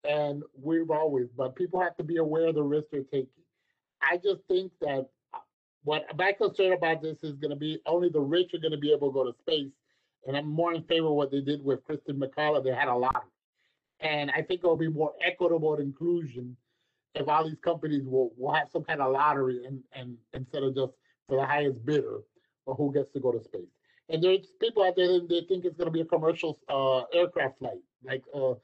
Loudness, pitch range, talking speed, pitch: -29 LUFS, 135-170 Hz, 225 wpm, 150 Hz